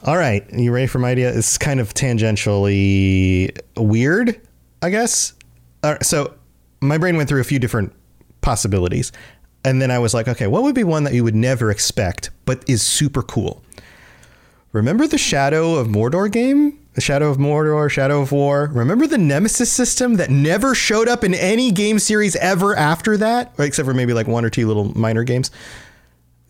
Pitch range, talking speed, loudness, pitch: 110-175 Hz, 185 wpm, -17 LUFS, 130 Hz